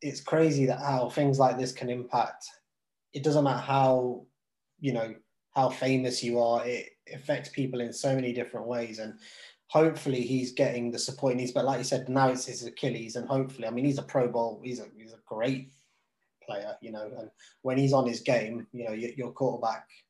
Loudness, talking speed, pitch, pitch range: -29 LUFS, 210 wpm, 125 Hz, 120-135 Hz